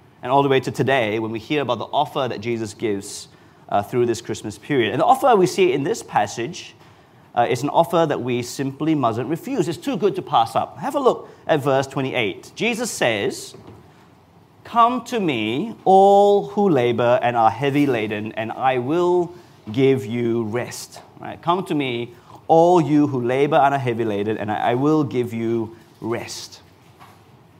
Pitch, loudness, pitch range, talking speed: 130 Hz, -20 LUFS, 115-160 Hz, 185 wpm